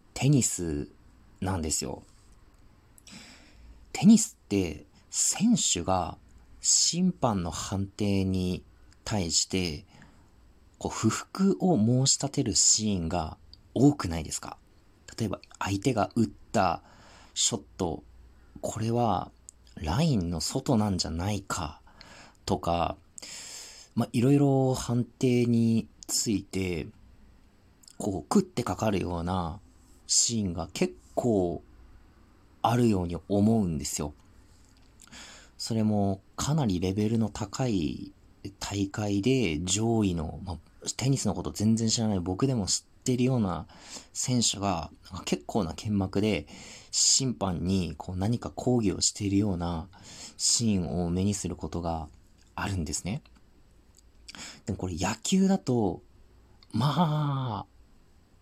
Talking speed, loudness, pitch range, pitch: 215 characters per minute, -28 LUFS, 90-110 Hz, 100 Hz